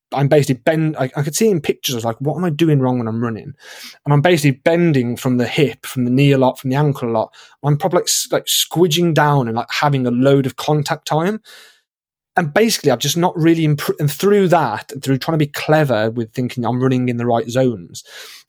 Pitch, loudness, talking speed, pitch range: 145 Hz, -16 LUFS, 235 wpm, 130-165 Hz